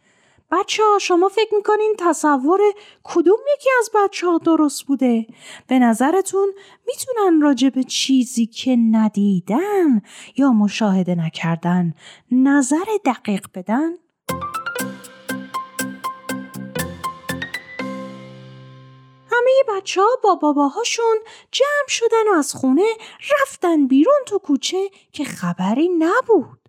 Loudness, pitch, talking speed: -18 LUFS, 295 Hz, 95 wpm